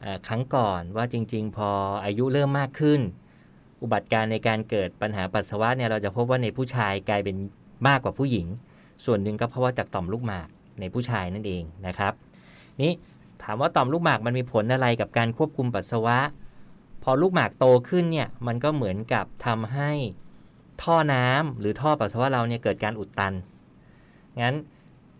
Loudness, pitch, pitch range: -25 LUFS, 120 Hz, 105-130 Hz